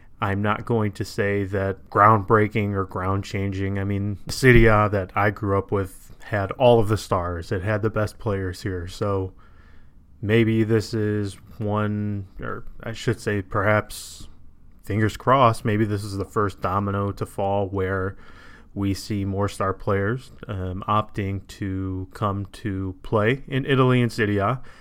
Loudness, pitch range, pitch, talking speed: -23 LUFS, 95-110 Hz, 100 Hz, 155 wpm